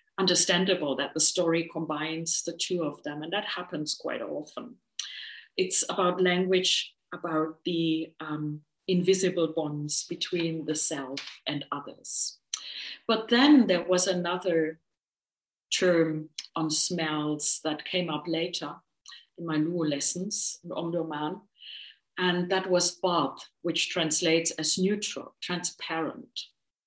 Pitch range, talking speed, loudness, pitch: 155-180 Hz, 120 wpm, -28 LUFS, 170 Hz